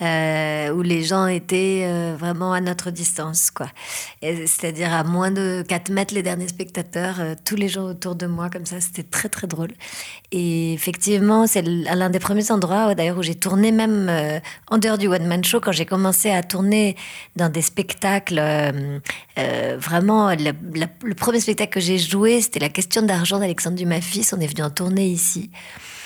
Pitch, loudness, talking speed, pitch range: 180 Hz, -20 LUFS, 195 wpm, 170-195 Hz